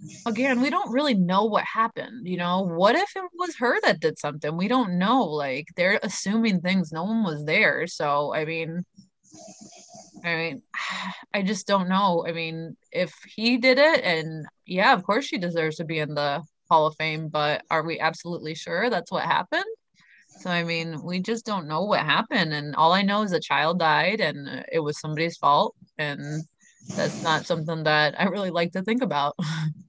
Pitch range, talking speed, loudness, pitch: 160-210 Hz, 195 wpm, -24 LUFS, 175 Hz